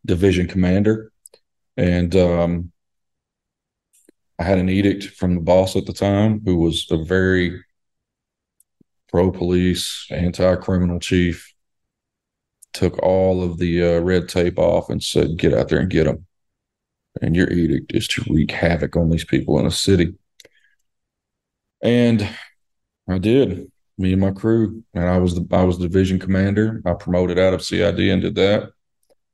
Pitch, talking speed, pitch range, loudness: 90 Hz, 155 wpm, 85-95 Hz, -19 LUFS